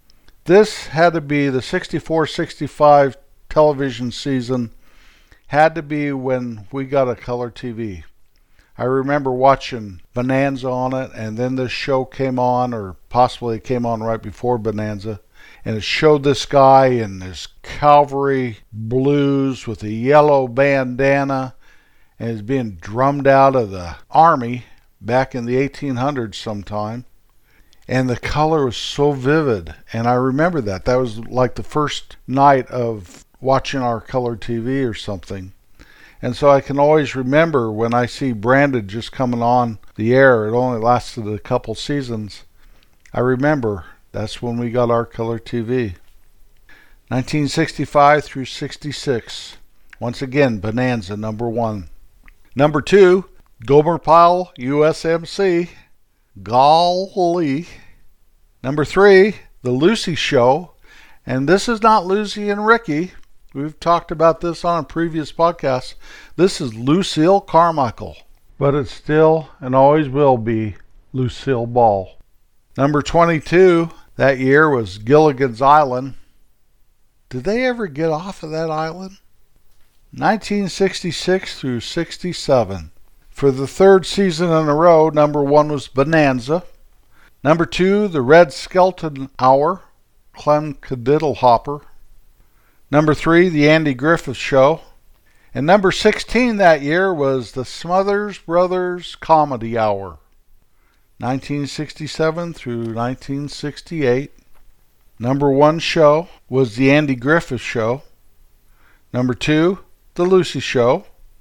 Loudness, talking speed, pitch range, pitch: -17 LUFS, 125 wpm, 120-155 Hz, 135 Hz